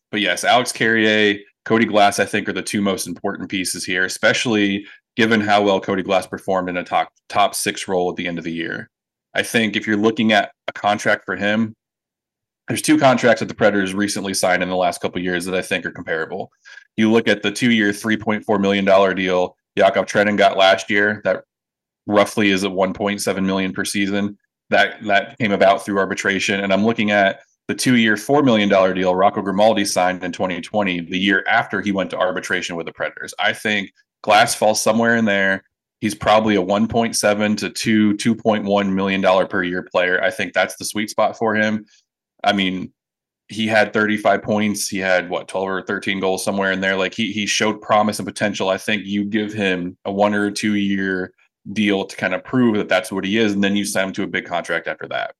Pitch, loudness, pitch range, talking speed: 100 Hz, -18 LUFS, 95-105 Hz, 210 wpm